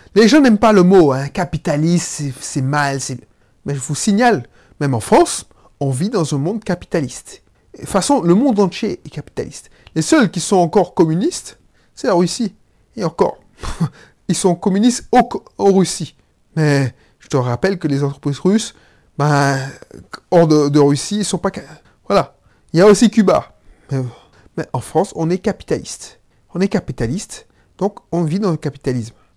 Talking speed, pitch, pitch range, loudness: 180 wpm, 170 Hz, 140-195 Hz, -16 LUFS